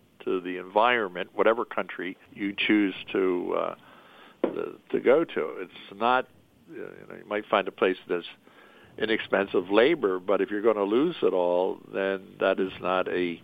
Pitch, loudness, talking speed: 350 Hz, -26 LUFS, 170 wpm